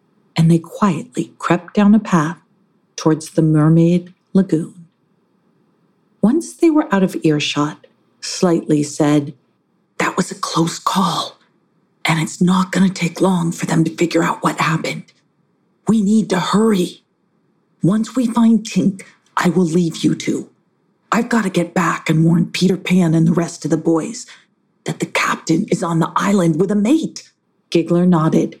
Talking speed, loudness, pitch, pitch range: 160 wpm, -17 LUFS, 180 Hz, 165-200 Hz